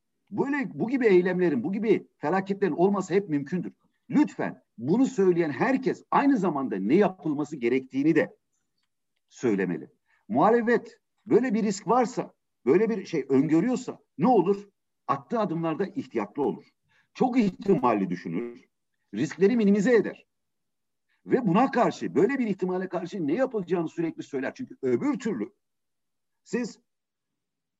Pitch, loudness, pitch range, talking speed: 200 Hz, -26 LUFS, 170-235 Hz, 125 wpm